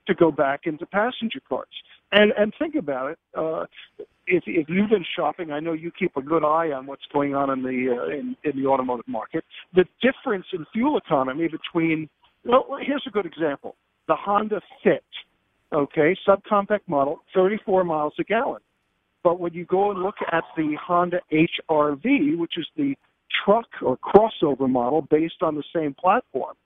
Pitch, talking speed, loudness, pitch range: 175 Hz, 180 wpm, -23 LUFS, 150-210 Hz